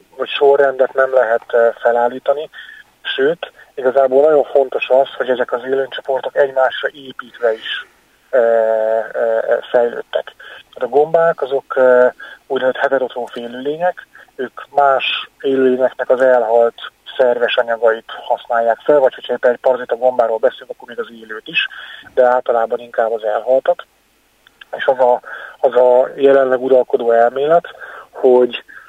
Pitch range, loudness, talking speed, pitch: 120-140 Hz, -15 LUFS, 125 wpm, 130 Hz